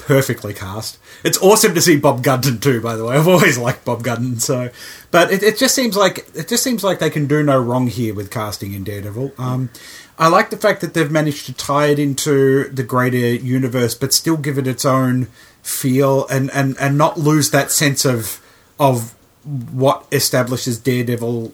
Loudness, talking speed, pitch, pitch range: -16 LUFS, 200 wpm, 135 Hz, 125-150 Hz